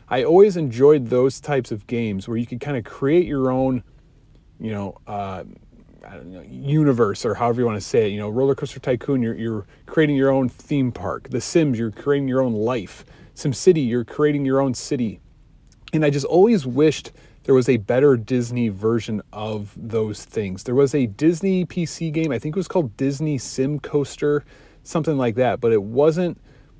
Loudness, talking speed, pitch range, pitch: -21 LUFS, 195 wpm, 115-145 Hz, 130 Hz